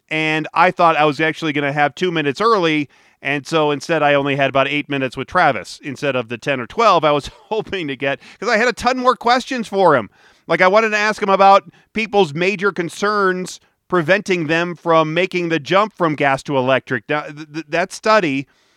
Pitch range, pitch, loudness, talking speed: 145-195 Hz, 165 Hz, -17 LUFS, 215 wpm